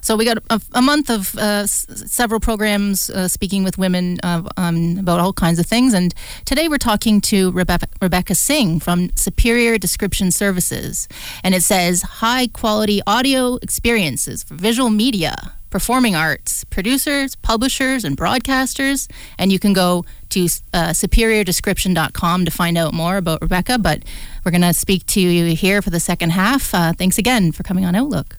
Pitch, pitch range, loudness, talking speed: 195 Hz, 175-230 Hz, -17 LUFS, 175 wpm